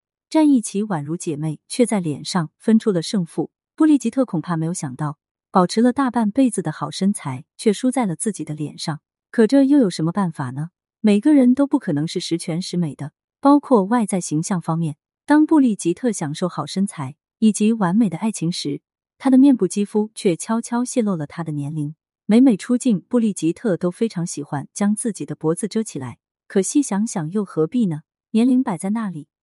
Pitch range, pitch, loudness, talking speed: 160-235 Hz, 195 Hz, -20 LUFS, 300 characters per minute